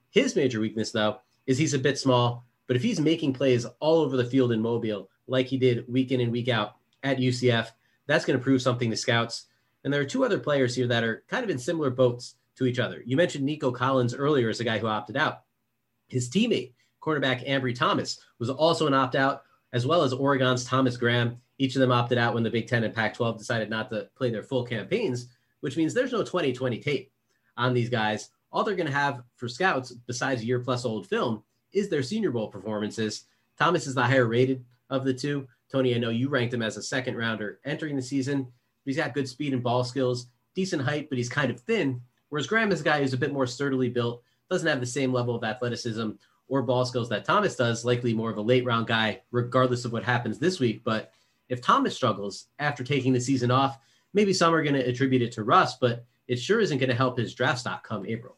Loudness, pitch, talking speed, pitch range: -26 LUFS, 125 Hz, 235 wpm, 120-135 Hz